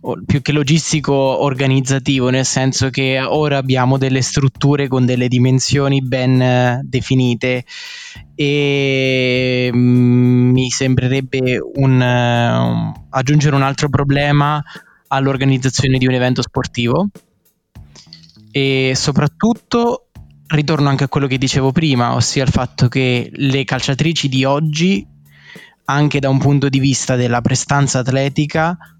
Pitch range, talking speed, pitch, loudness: 125-140 Hz, 120 wpm, 135 Hz, -15 LUFS